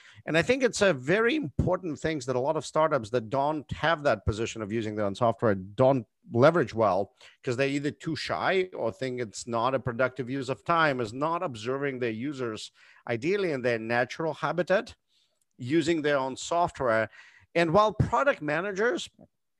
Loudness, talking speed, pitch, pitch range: -28 LUFS, 180 wpm, 135 Hz, 120-165 Hz